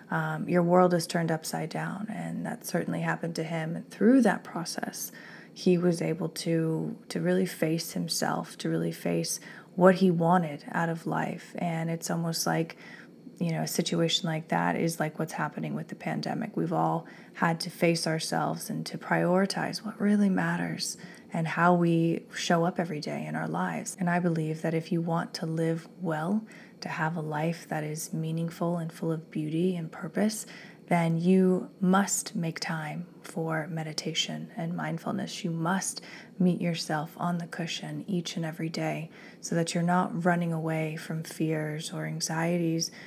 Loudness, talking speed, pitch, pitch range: -29 LUFS, 175 wpm, 170 Hz, 160-180 Hz